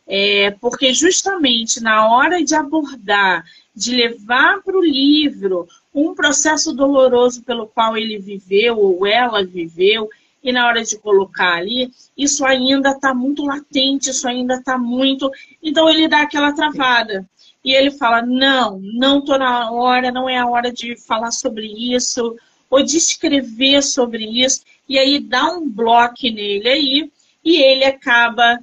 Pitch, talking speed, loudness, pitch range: 260 Hz, 155 wpm, -15 LUFS, 235-290 Hz